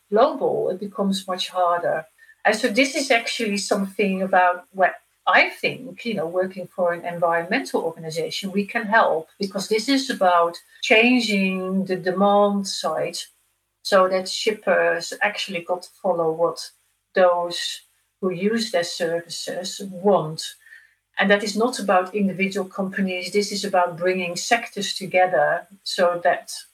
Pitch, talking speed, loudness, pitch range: 195 Hz, 140 wpm, -22 LUFS, 180-215 Hz